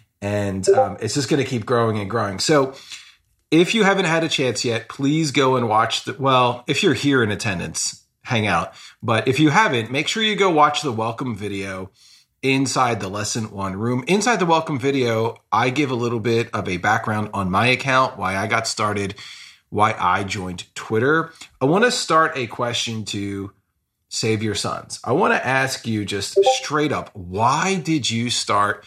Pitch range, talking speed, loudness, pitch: 105-145 Hz, 195 wpm, -20 LUFS, 120 Hz